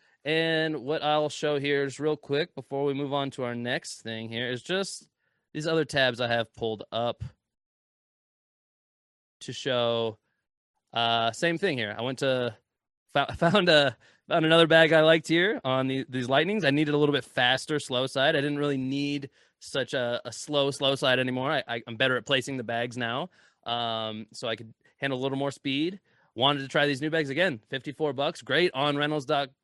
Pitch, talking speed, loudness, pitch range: 135 Hz, 195 wpm, -27 LUFS, 120-150 Hz